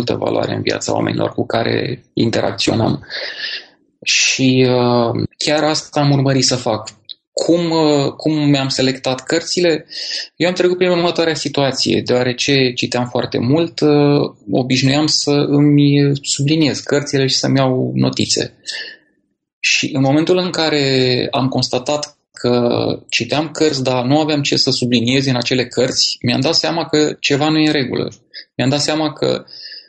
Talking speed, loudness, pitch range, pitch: 150 wpm, -15 LUFS, 130-155 Hz, 140 Hz